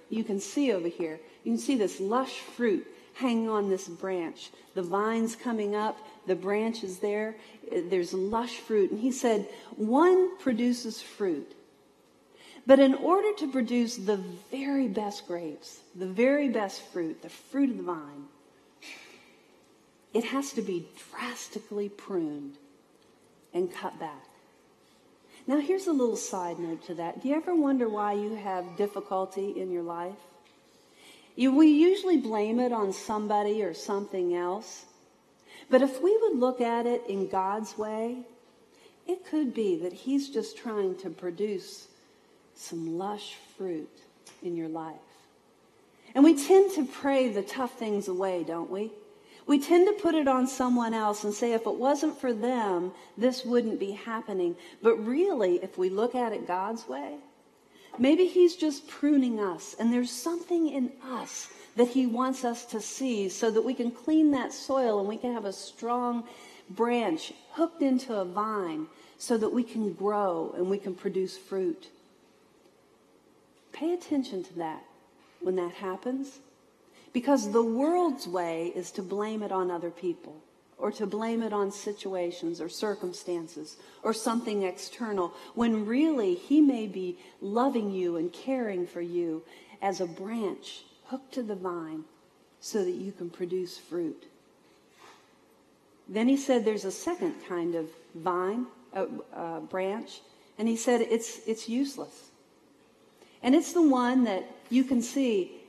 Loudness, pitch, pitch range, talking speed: -29 LUFS, 225 Hz, 190-270 Hz, 155 wpm